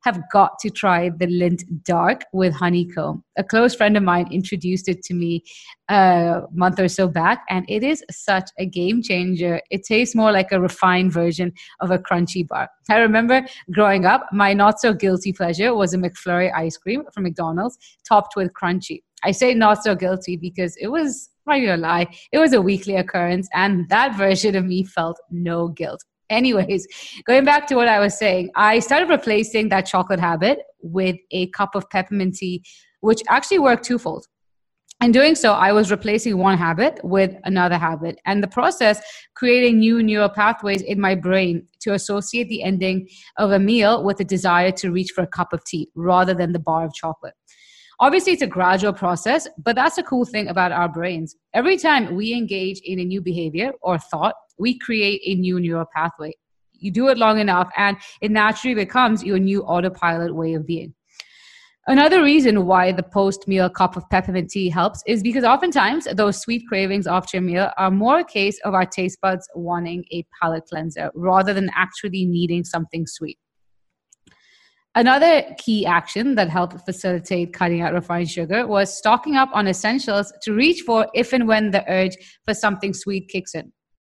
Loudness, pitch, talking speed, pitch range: -19 LUFS, 190 Hz, 185 wpm, 180-220 Hz